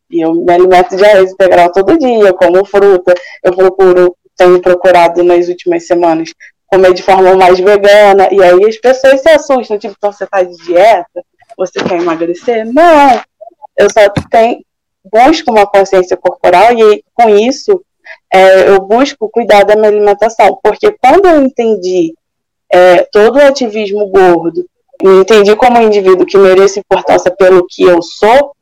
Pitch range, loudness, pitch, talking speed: 180-230 Hz, -7 LUFS, 195 Hz, 160 wpm